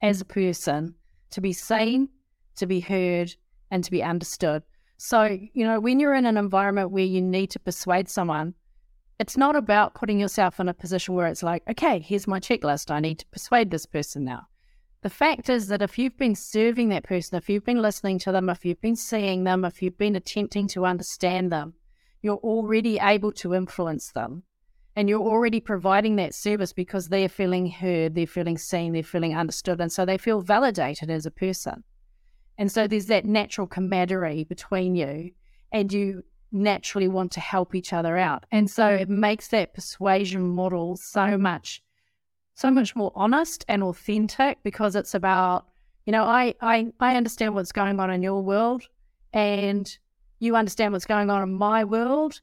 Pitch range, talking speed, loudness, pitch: 180-215 Hz, 185 wpm, -24 LUFS, 195 Hz